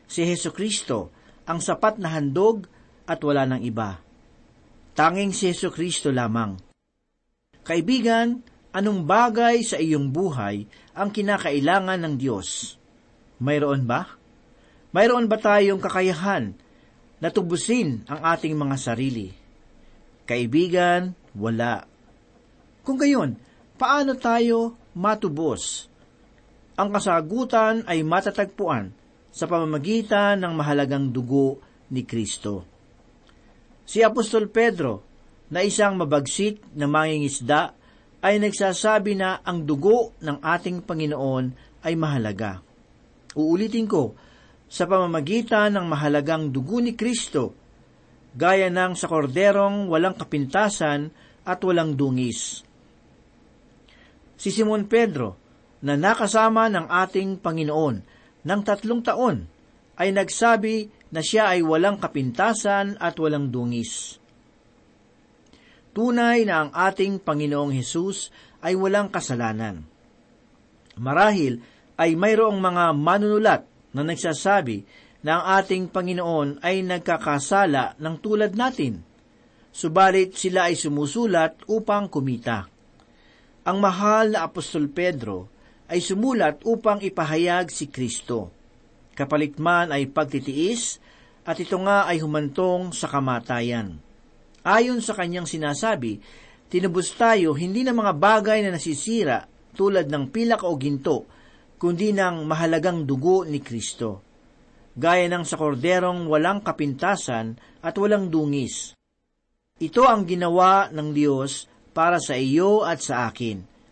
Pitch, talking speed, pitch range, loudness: 175 Hz, 110 wpm, 145-200 Hz, -23 LUFS